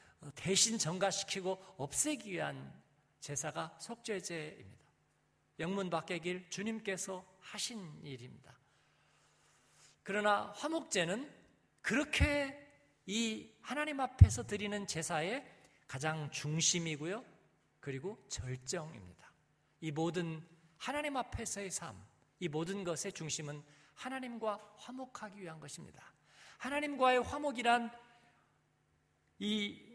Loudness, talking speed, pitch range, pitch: -37 LUFS, 235 characters per minute, 155-225 Hz, 190 Hz